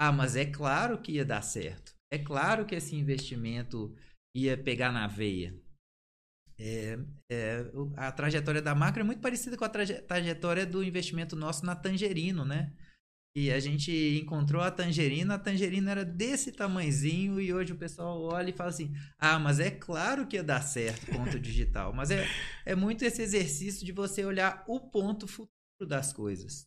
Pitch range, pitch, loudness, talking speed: 135-190 Hz, 155 Hz, -32 LUFS, 180 wpm